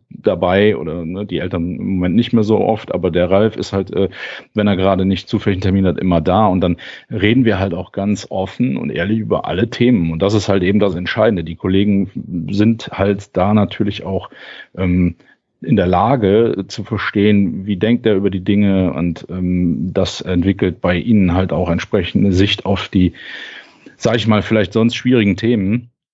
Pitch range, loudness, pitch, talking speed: 90-105 Hz, -16 LUFS, 100 Hz, 195 wpm